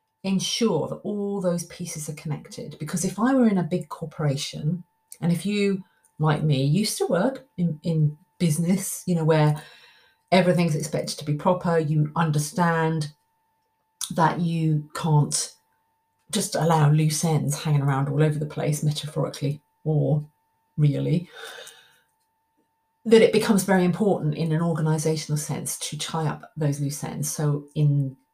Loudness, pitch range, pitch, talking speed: -24 LUFS, 150-195 Hz, 165 Hz, 145 wpm